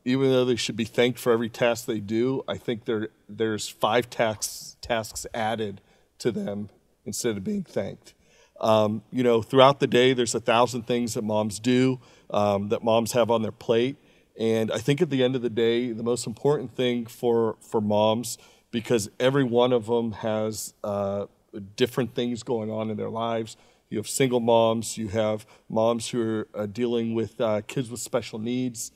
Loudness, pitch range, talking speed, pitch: -25 LUFS, 110-125 Hz, 190 wpm, 115 Hz